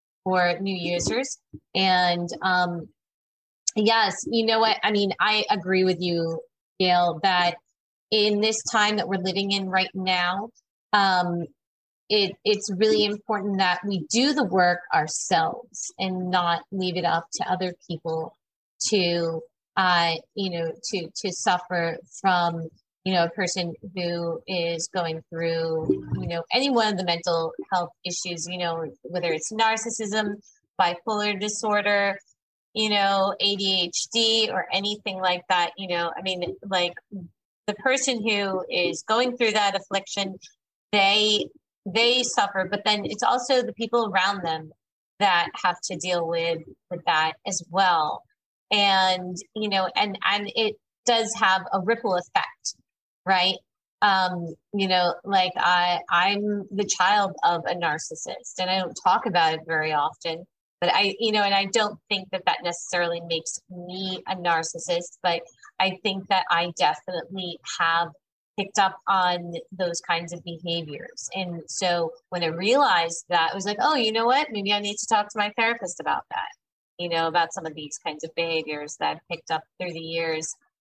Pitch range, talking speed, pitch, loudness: 175-205 Hz, 160 wpm, 185 Hz, -24 LUFS